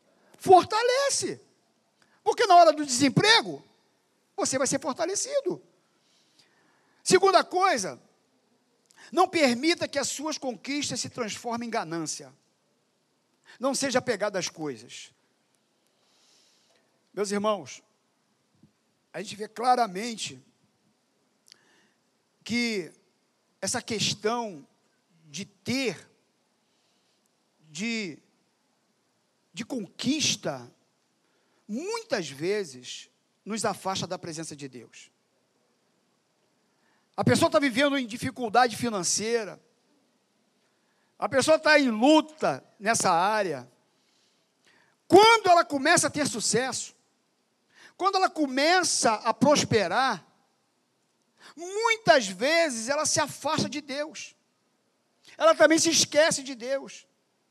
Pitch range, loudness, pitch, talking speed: 210-315 Hz, -25 LUFS, 260 Hz, 90 wpm